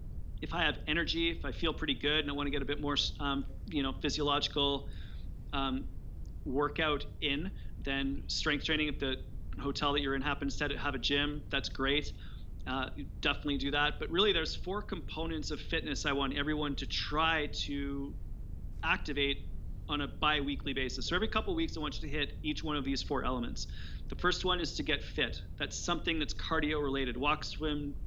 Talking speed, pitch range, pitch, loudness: 200 wpm, 135-150 Hz, 145 Hz, -34 LUFS